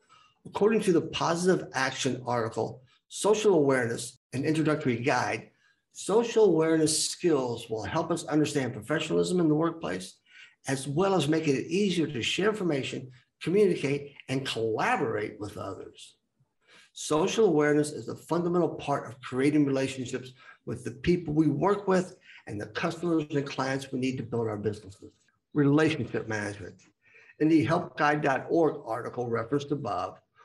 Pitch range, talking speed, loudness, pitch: 125-165 Hz, 140 wpm, -28 LUFS, 145 Hz